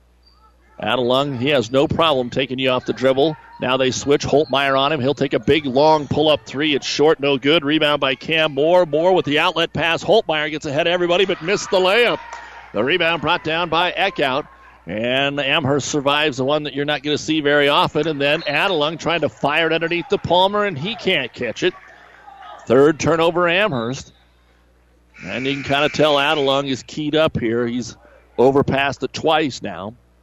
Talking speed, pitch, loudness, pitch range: 195 wpm, 145 Hz, -18 LUFS, 135-165 Hz